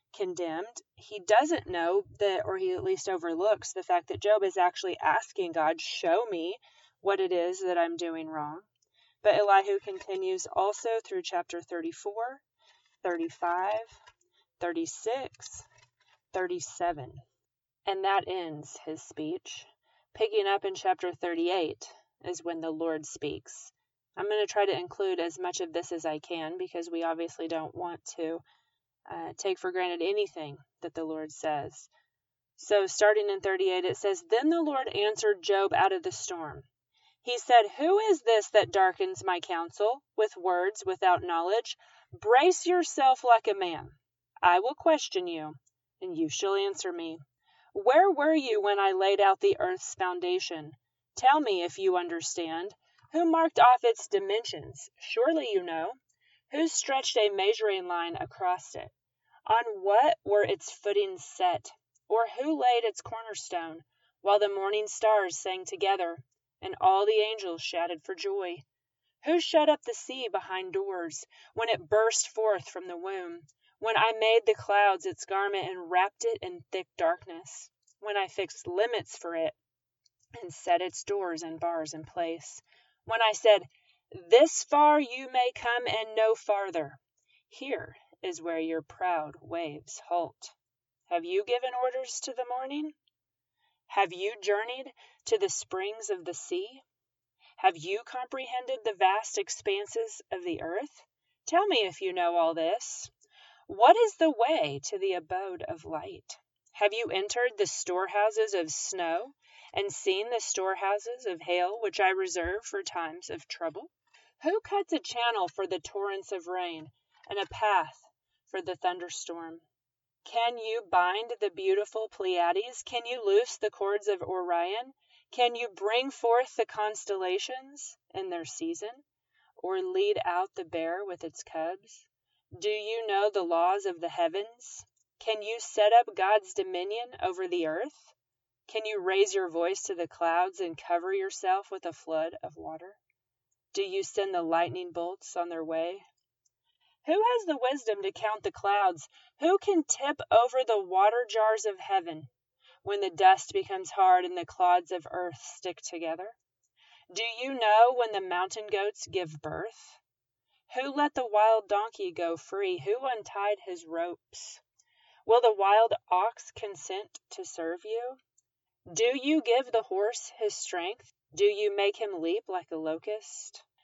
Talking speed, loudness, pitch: 160 wpm, -29 LUFS, 210 Hz